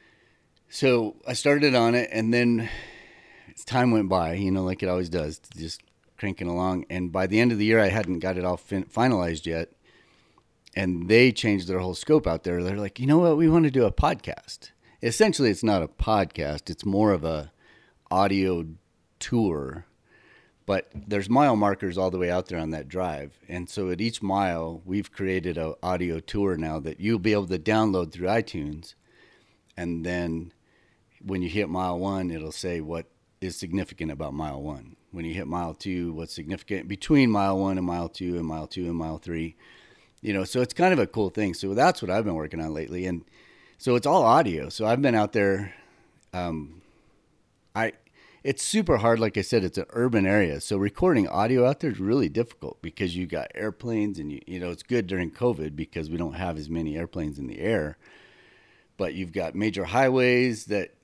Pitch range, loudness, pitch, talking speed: 85-110 Hz, -26 LUFS, 95 Hz, 200 wpm